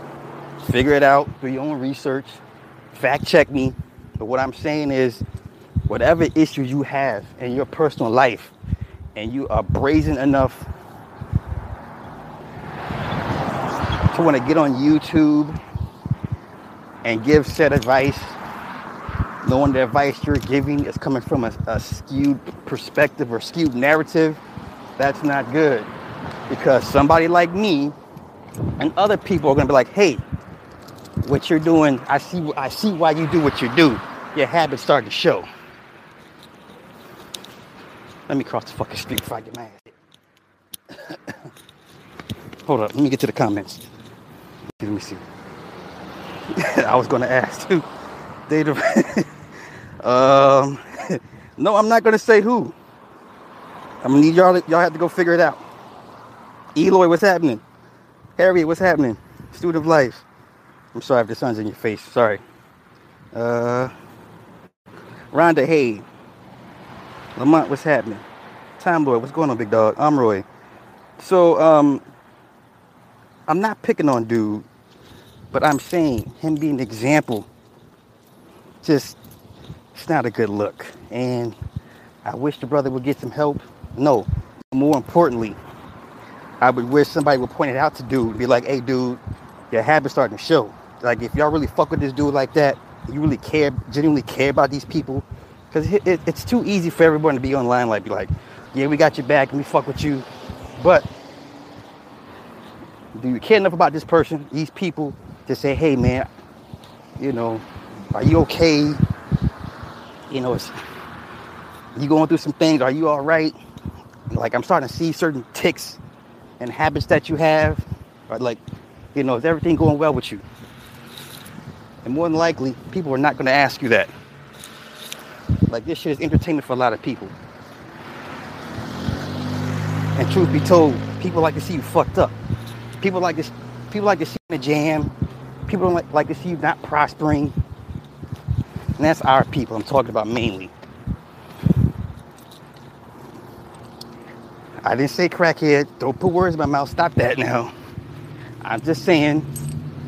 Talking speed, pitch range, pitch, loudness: 155 wpm, 120-155 Hz, 140 Hz, -19 LUFS